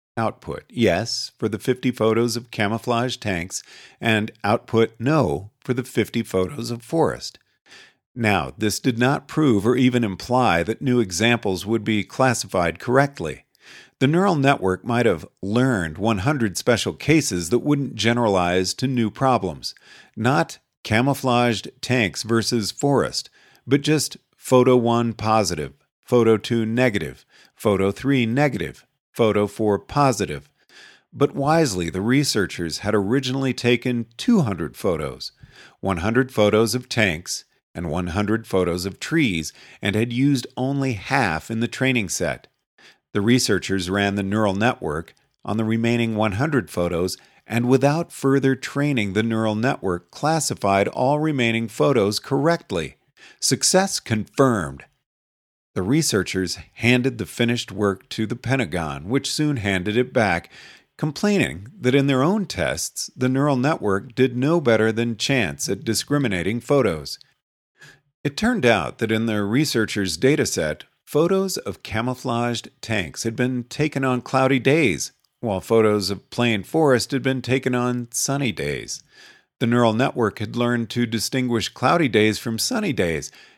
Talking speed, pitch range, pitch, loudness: 135 wpm, 105-130 Hz, 120 Hz, -21 LUFS